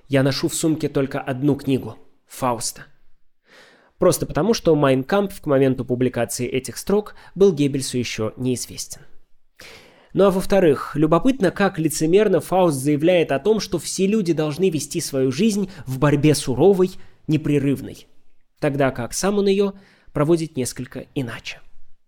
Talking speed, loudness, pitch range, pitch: 135 wpm, -20 LUFS, 135-185 Hz, 150 Hz